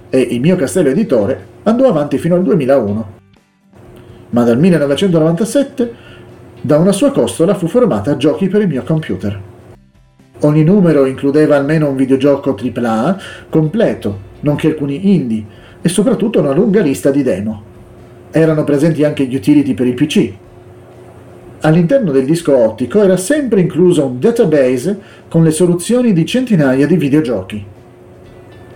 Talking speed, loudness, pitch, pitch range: 140 wpm, -13 LUFS, 145 Hz, 120-180 Hz